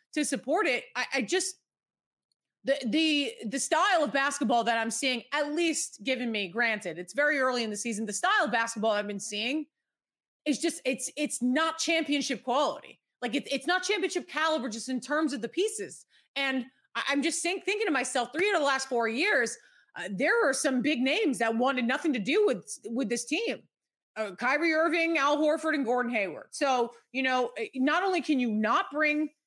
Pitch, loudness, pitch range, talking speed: 275 Hz, -28 LUFS, 240-315 Hz, 200 wpm